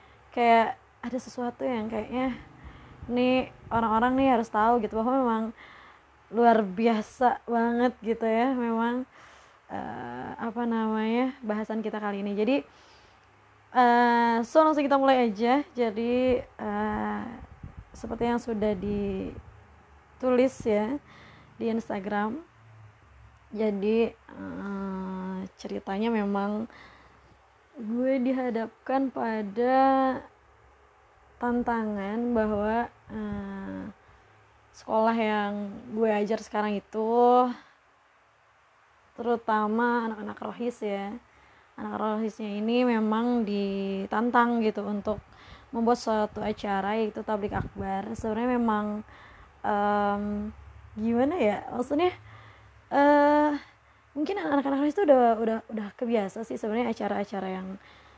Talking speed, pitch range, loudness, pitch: 95 wpm, 210-245 Hz, -27 LUFS, 225 Hz